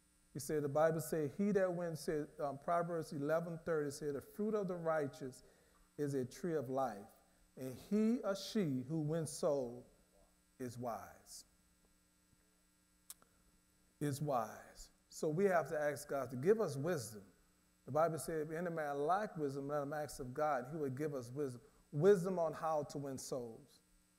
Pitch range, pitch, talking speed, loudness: 100-160 Hz, 145 Hz, 170 wpm, -39 LUFS